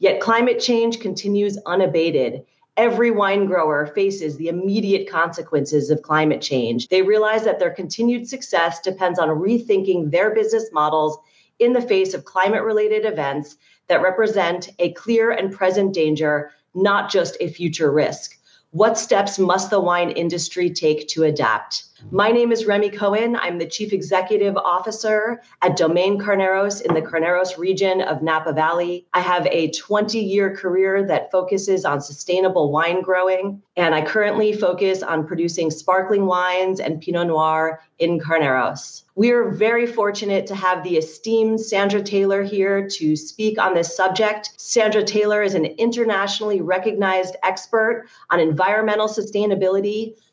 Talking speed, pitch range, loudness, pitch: 150 wpm, 170-210 Hz, -19 LUFS, 190 Hz